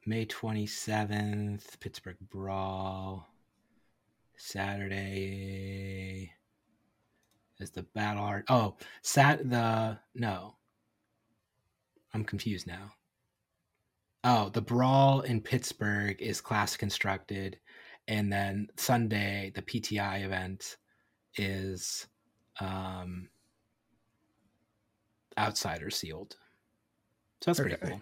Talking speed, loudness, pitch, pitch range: 80 wpm, -32 LUFS, 105 Hz, 95-110 Hz